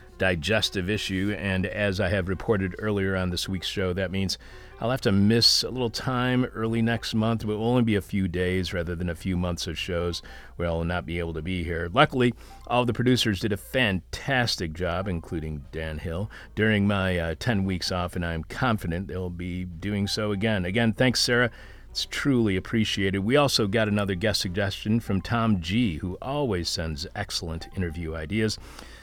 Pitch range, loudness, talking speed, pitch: 90-110 Hz, -26 LUFS, 190 wpm, 95 Hz